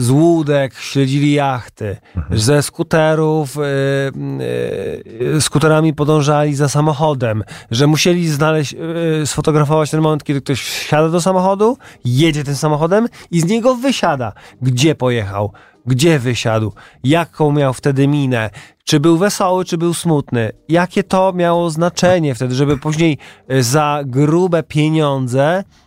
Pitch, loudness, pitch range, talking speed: 150 Hz, -15 LUFS, 135-165 Hz, 130 wpm